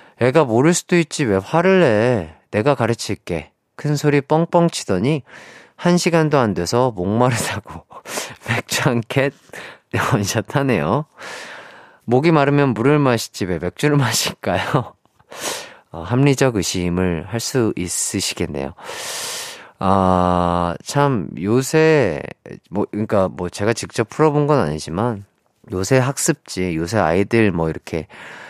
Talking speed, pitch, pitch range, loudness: 245 characters per minute, 115 Hz, 95-145 Hz, -18 LUFS